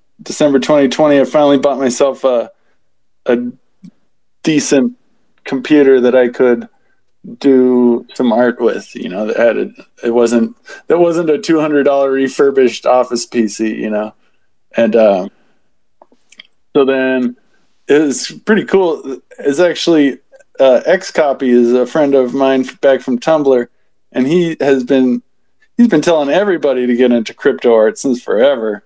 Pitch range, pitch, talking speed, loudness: 120-145 Hz, 130 Hz, 145 wpm, -12 LUFS